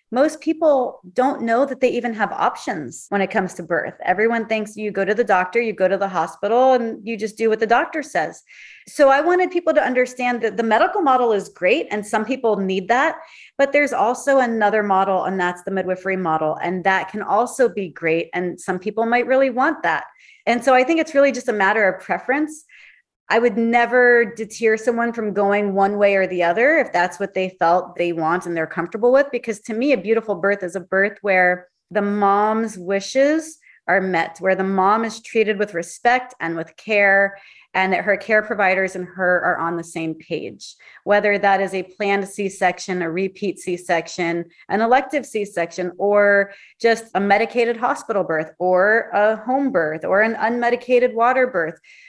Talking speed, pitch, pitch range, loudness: 200 wpm, 210 Hz, 190-245 Hz, -19 LUFS